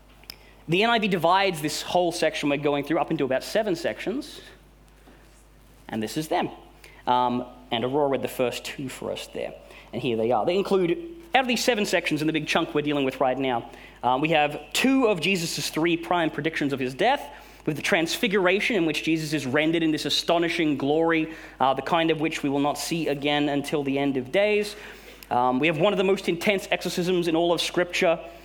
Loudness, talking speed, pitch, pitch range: -24 LUFS, 210 wpm, 160 Hz, 140-180 Hz